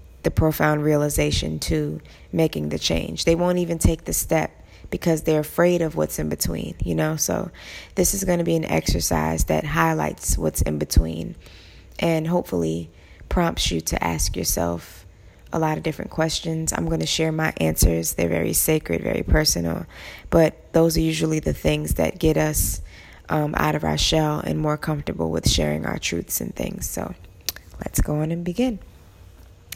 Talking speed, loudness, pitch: 175 wpm, -22 LUFS, 90 Hz